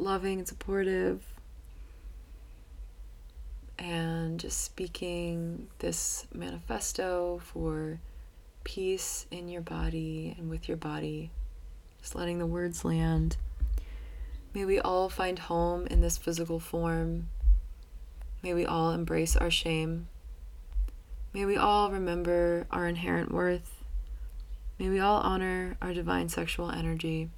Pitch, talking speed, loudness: 160 Hz, 115 wpm, -32 LUFS